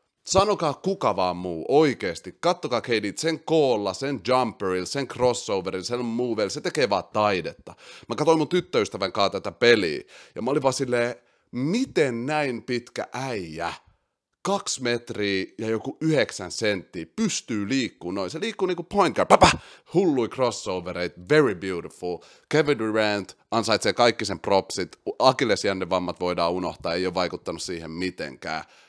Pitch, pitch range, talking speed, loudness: 120 Hz, 95-155 Hz, 140 wpm, -25 LUFS